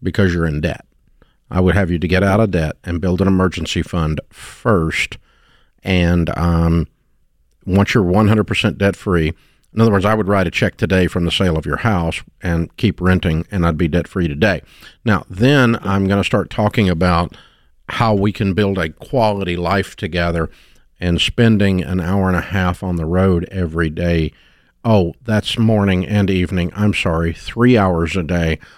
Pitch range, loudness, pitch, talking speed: 85-100 Hz, -17 LUFS, 90 Hz, 185 wpm